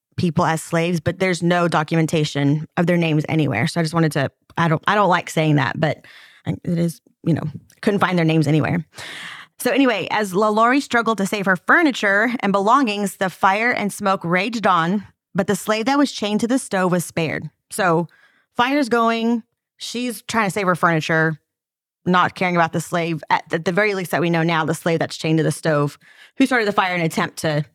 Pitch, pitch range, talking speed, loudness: 175 Hz, 160-210 Hz, 215 wpm, -19 LUFS